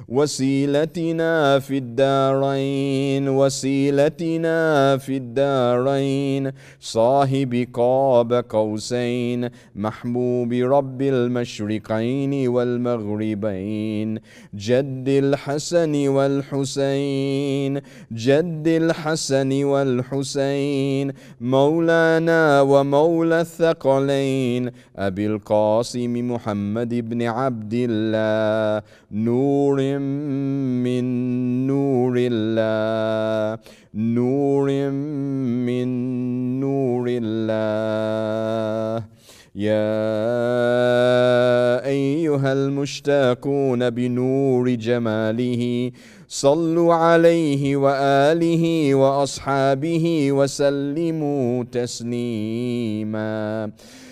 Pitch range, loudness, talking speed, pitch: 120-140 Hz, -20 LUFS, 50 wpm, 130 Hz